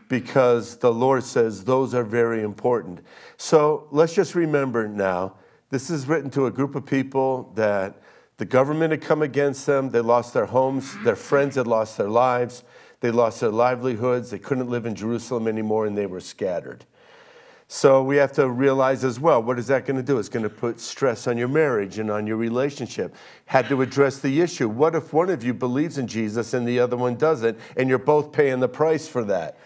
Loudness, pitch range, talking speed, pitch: -22 LUFS, 120-140 Hz, 210 wpm, 130 Hz